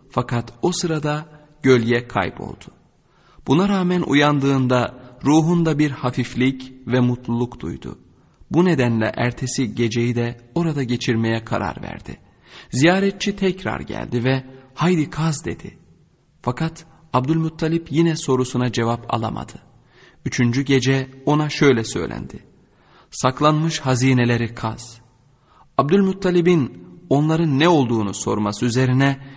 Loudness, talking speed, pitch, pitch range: -20 LUFS, 100 wpm, 130 Hz, 120-160 Hz